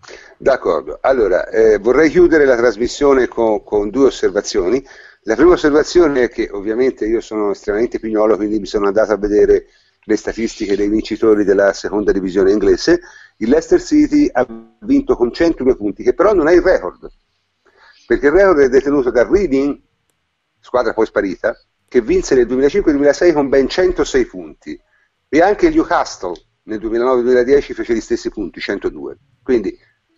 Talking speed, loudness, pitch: 155 wpm, -15 LUFS, 345 Hz